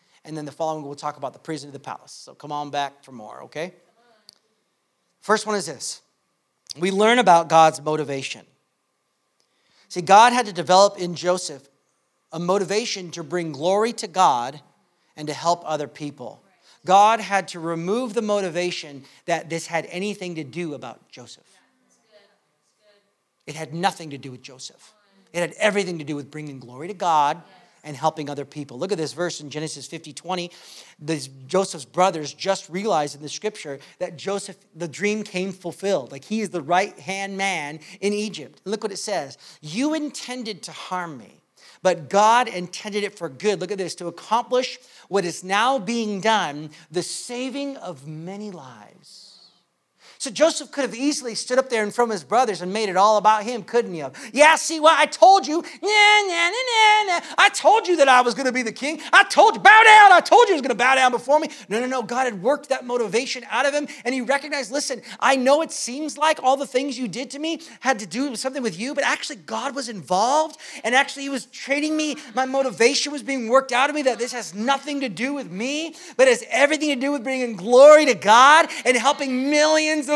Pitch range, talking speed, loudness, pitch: 170-265 Hz, 210 wpm, -20 LUFS, 210 Hz